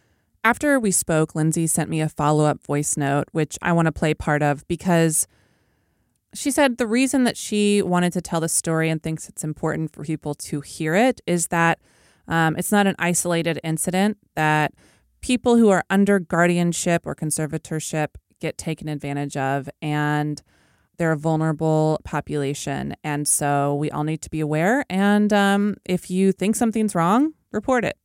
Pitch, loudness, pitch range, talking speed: 165 Hz, -21 LUFS, 155-195 Hz, 175 wpm